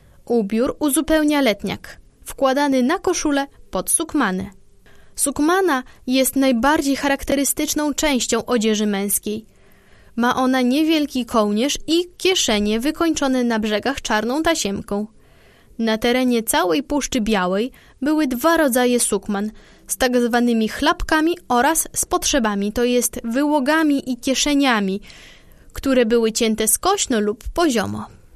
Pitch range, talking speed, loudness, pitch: 220-300 Hz, 110 wpm, -19 LUFS, 255 Hz